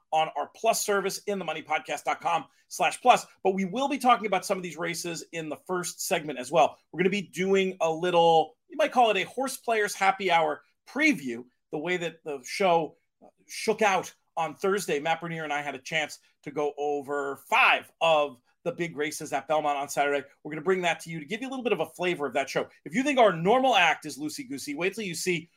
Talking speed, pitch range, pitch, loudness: 240 wpm, 155-205 Hz, 170 Hz, -27 LUFS